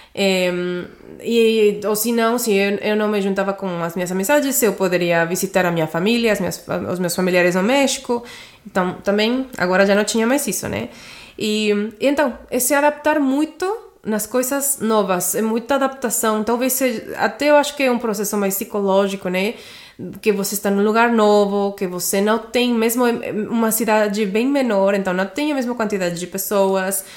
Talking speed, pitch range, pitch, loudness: 190 wpm, 195-240 Hz, 210 Hz, -18 LUFS